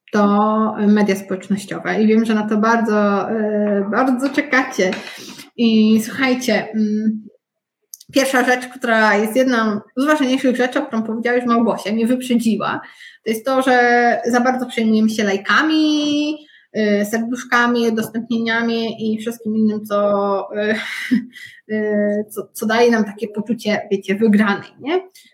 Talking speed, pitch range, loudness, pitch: 135 wpm, 210-250 Hz, -17 LUFS, 225 Hz